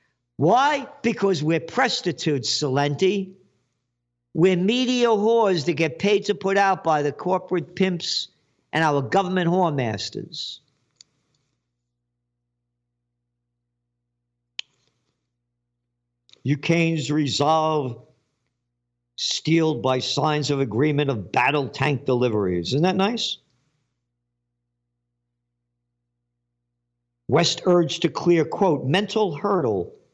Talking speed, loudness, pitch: 90 wpm, -22 LUFS, 140 Hz